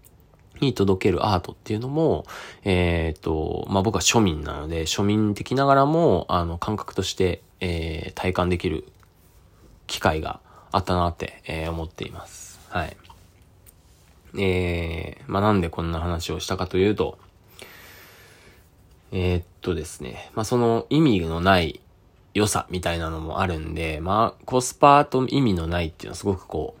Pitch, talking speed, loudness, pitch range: 90 Hz, 305 characters per minute, -23 LUFS, 85-105 Hz